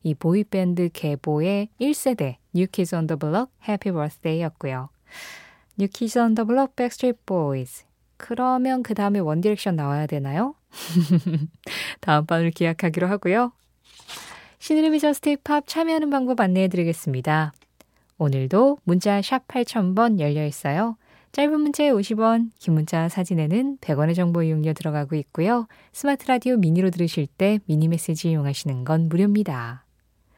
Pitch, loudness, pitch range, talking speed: 185 Hz, -23 LUFS, 155-235 Hz, 385 characters per minute